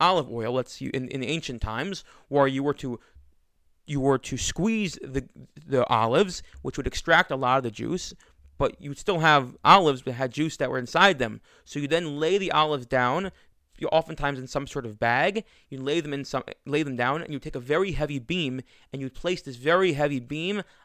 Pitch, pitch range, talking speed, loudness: 140 Hz, 130-160 Hz, 220 wpm, -25 LUFS